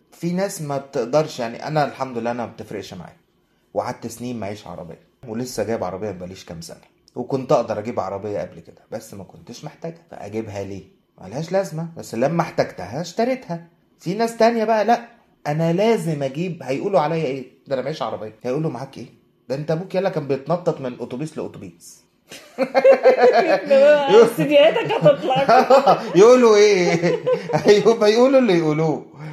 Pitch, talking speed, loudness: 160 Hz, 145 wpm, -19 LUFS